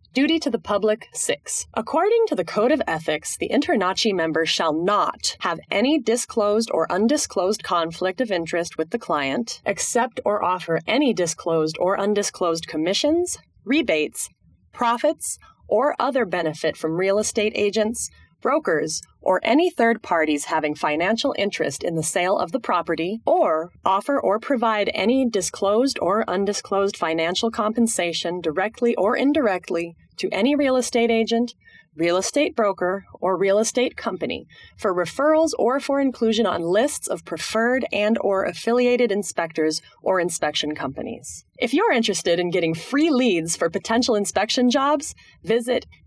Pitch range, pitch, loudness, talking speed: 175-250 Hz, 215 Hz, -22 LUFS, 145 wpm